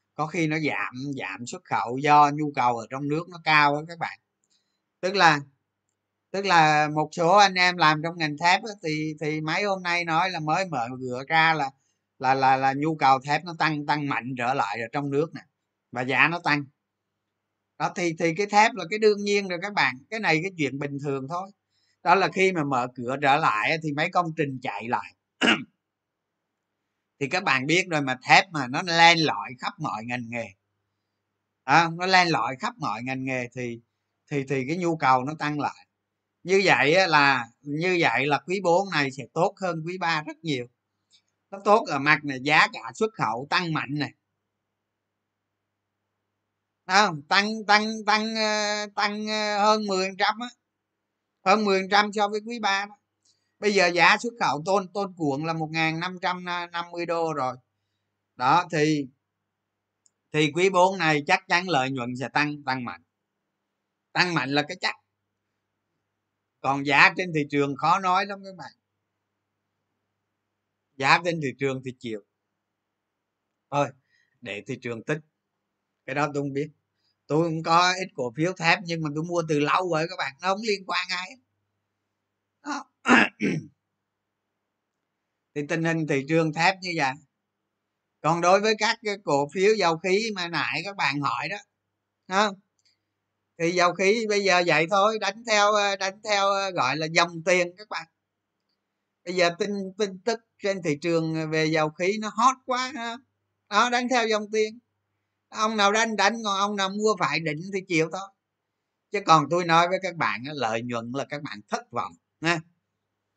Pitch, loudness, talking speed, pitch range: 150 Hz, -24 LUFS, 180 wpm, 110-180 Hz